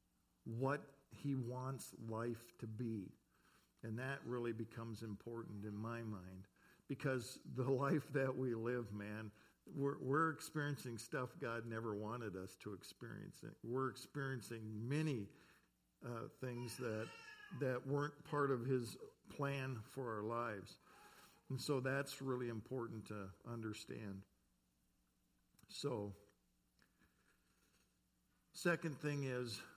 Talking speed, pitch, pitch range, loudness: 115 wpm, 120 Hz, 110-135 Hz, -45 LUFS